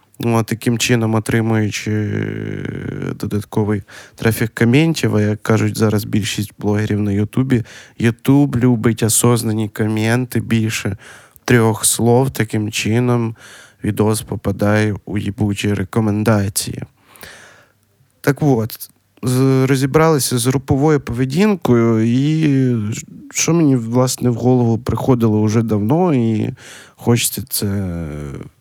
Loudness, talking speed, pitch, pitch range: -17 LUFS, 100 wpm, 115 Hz, 105-130 Hz